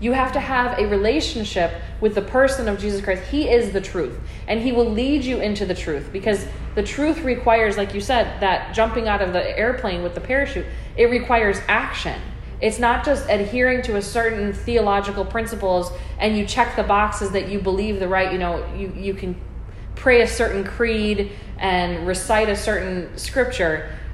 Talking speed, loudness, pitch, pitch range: 190 wpm, -21 LUFS, 210 Hz, 195-240 Hz